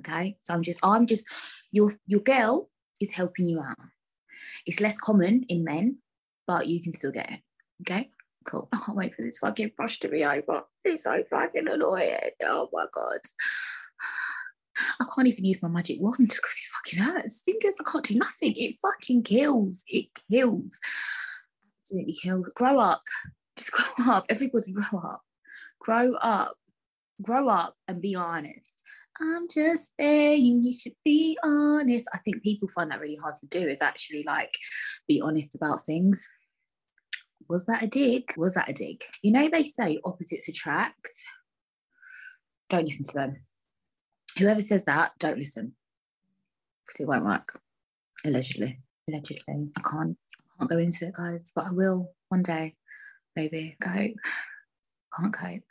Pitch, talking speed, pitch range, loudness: 200 Hz, 165 wpm, 170-260 Hz, -27 LUFS